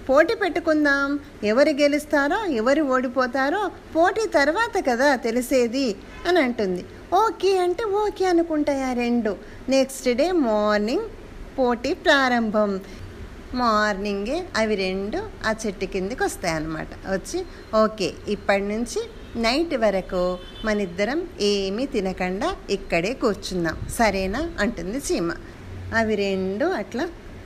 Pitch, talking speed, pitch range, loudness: 255 Hz, 100 wpm, 205-315 Hz, -23 LUFS